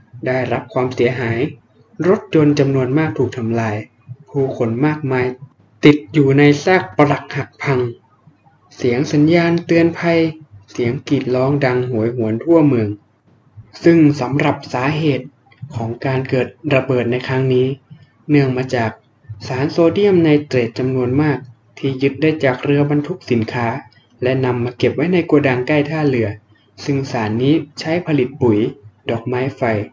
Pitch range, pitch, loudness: 120-150 Hz, 130 Hz, -17 LUFS